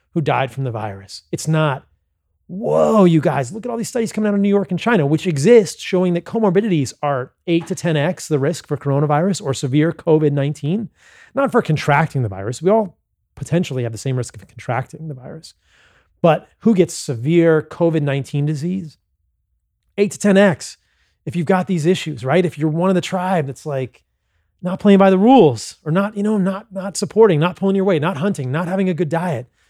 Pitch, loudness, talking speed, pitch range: 165 Hz, -18 LUFS, 200 wpm, 140-190 Hz